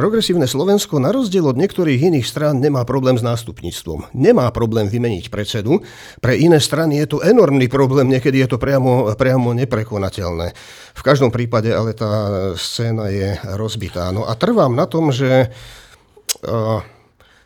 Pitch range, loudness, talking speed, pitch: 110-145 Hz, -16 LUFS, 150 wpm, 125 Hz